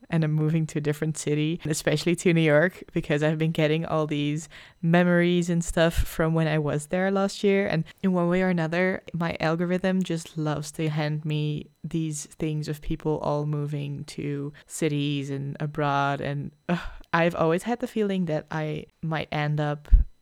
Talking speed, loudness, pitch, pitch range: 185 wpm, -26 LUFS, 160 Hz, 150-175 Hz